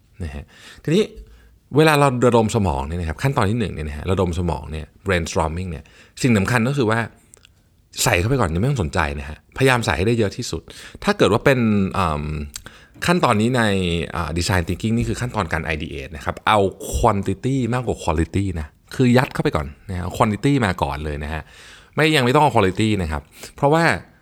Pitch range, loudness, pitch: 80-120 Hz, -20 LUFS, 100 Hz